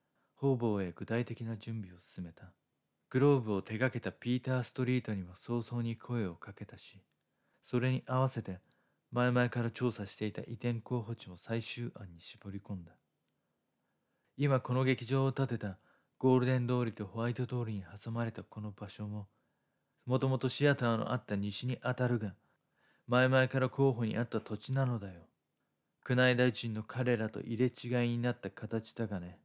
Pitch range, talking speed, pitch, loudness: 105-125 Hz, 330 characters per minute, 120 Hz, -34 LUFS